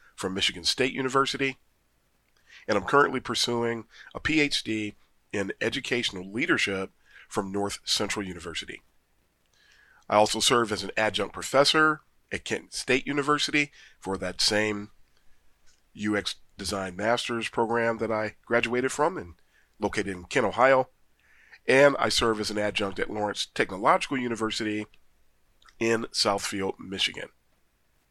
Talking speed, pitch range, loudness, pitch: 120 wpm, 100-130 Hz, -26 LUFS, 110 Hz